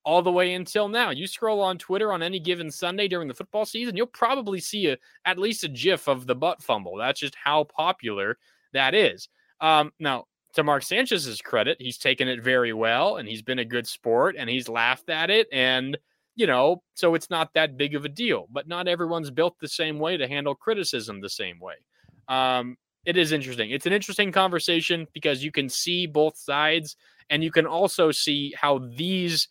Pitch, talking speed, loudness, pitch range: 160 Hz, 205 wpm, -24 LUFS, 140-185 Hz